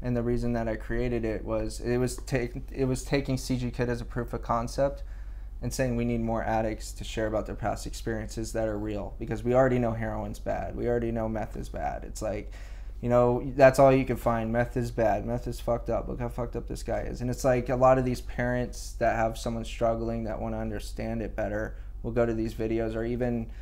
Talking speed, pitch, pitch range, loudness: 245 wpm, 115 Hz, 110-120 Hz, -29 LUFS